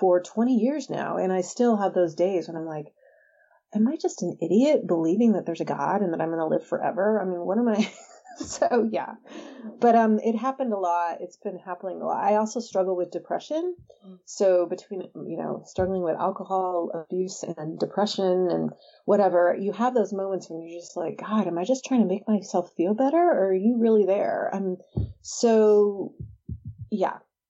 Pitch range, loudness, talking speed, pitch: 180-230 Hz, -25 LUFS, 200 wpm, 195 Hz